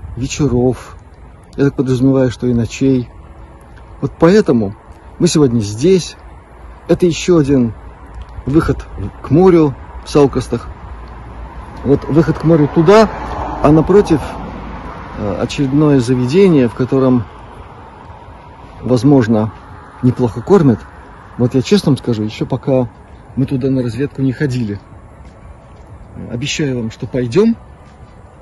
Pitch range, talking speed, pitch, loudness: 95-145 Hz, 110 wpm, 125 Hz, -14 LUFS